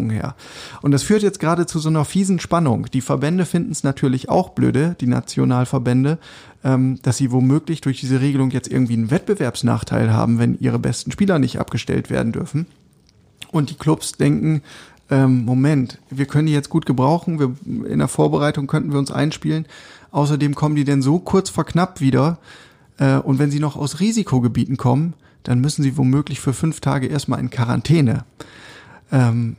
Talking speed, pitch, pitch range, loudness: 180 wpm, 140 Hz, 130-155 Hz, -19 LUFS